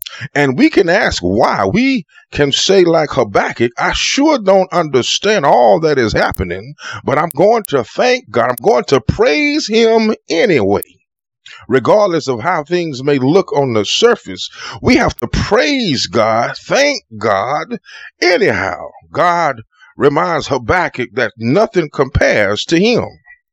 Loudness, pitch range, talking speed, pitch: -13 LUFS, 140-230 Hz, 140 wpm, 175 Hz